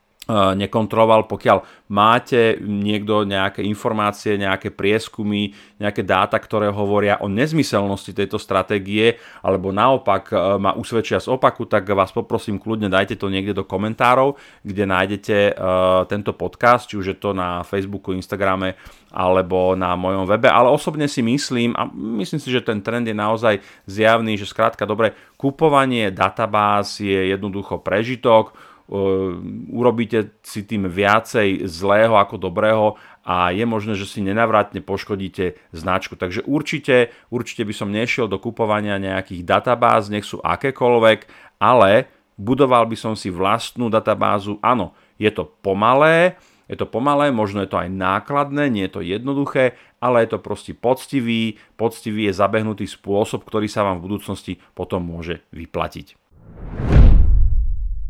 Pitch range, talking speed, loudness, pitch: 95-115 Hz, 140 wpm, -19 LUFS, 105 Hz